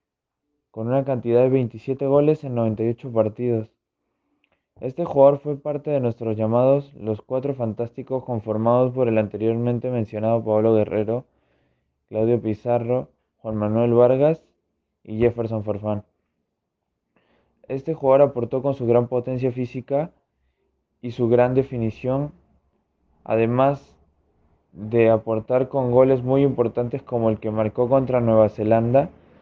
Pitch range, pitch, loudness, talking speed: 110-130 Hz, 120 Hz, -21 LUFS, 120 wpm